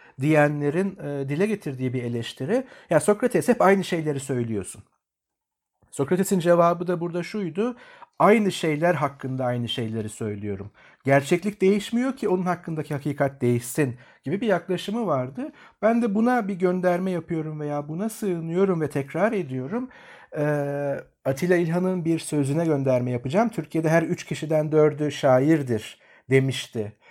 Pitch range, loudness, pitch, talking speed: 140-190 Hz, -24 LUFS, 160 Hz, 130 wpm